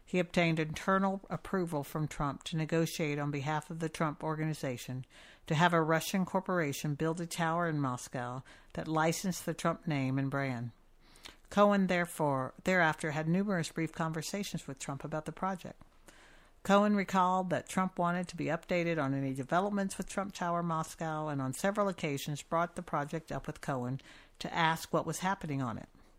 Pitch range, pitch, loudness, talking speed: 145-180 Hz, 160 Hz, -33 LUFS, 170 wpm